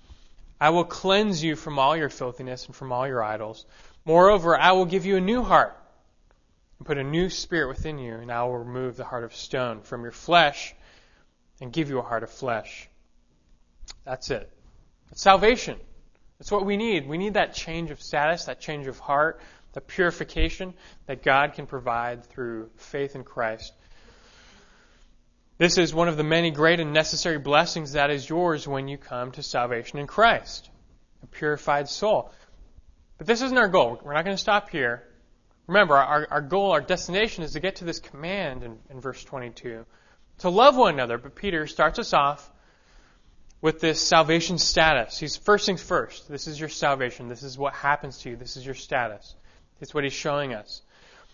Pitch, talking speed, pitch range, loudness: 145 Hz, 185 wpm, 125-170 Hz, -24 LUFS